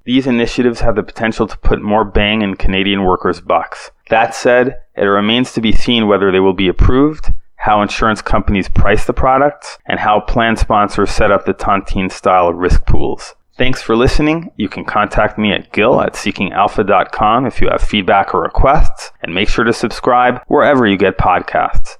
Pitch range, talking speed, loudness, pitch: 100-125 Hz, 185 wpm, -13 LUFS, 110 Hz